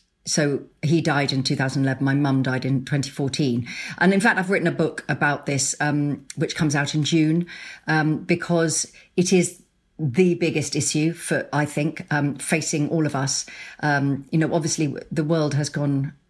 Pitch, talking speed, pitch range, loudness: 150 Hz, 175 wpm, 140-165 Hz, -22 LUFS